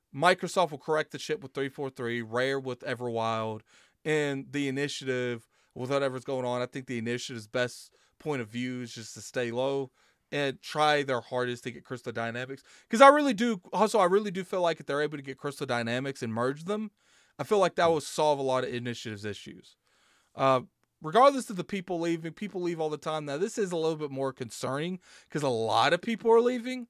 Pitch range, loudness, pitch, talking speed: 125-175 Hz, -29 LUFS, 140 Hz, 210 wpm